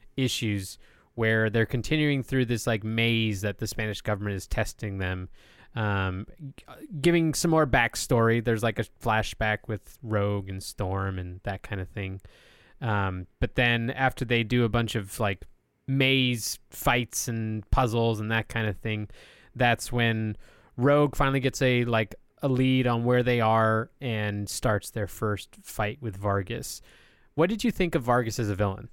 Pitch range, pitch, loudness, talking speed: 105-125 Hz, 115 Hz, -27 LUFS, 170 wpm